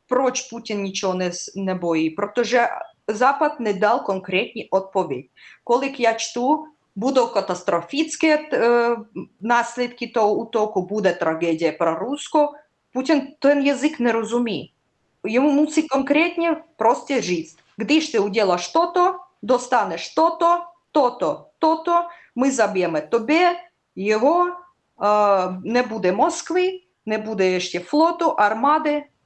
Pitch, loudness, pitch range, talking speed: 240 Hz, -21 LUFS, 200-305 Hz, 115 wpm